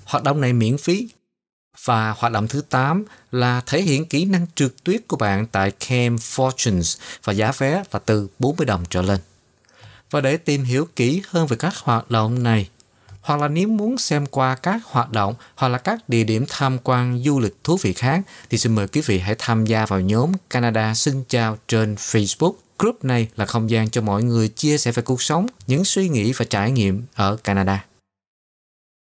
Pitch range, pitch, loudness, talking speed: 110-145 Hz, 120 Hz, -20 LUFS, 205 wpm